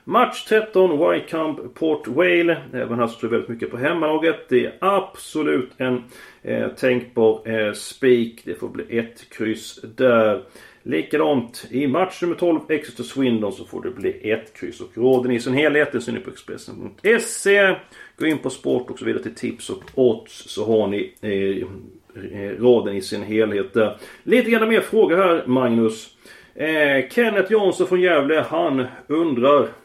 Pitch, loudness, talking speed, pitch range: 135 Hz, -20 LUFS, 165 wpm, 115-180 Hz